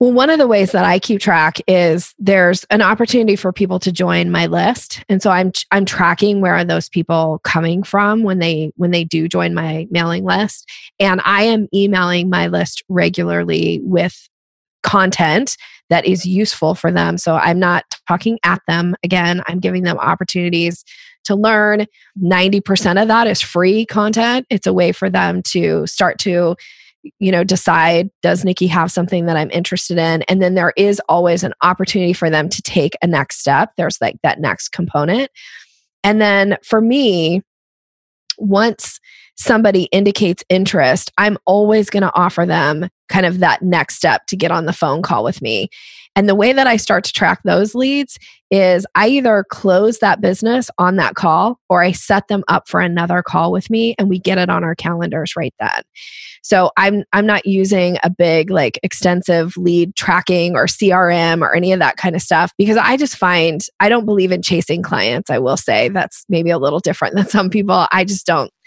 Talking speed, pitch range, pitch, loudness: 190 wpm, 175-205 Hz, 185 Hz, -14 LUFS